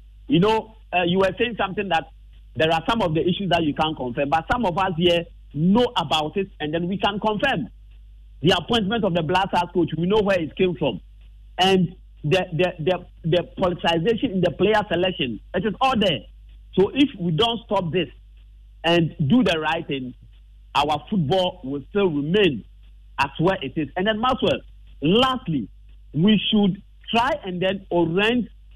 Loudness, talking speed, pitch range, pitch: -22 LUFS, 185 wpm, 160-200 Hz, 180 Hz